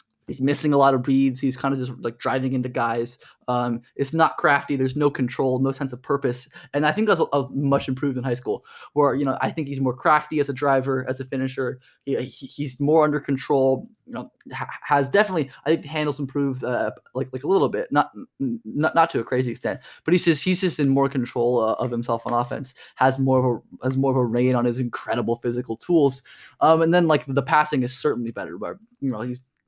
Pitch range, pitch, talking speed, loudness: 125-145 Hz, 135 Hz, 235 wpm, -23 LUFS